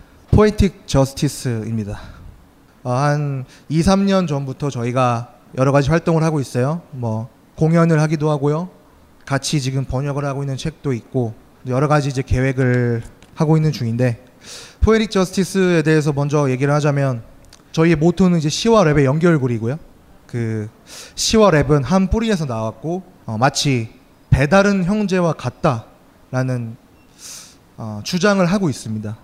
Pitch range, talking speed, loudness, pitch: 125-160 Hz, 300 characters per minute, -18 LUFS, 140 Hz